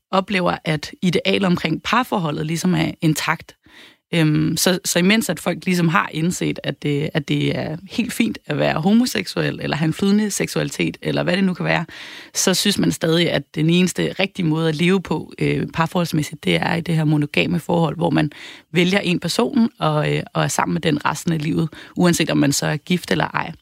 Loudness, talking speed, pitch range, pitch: -19 LUFS, 190 wpm, 155-185 Hz, 170 Hz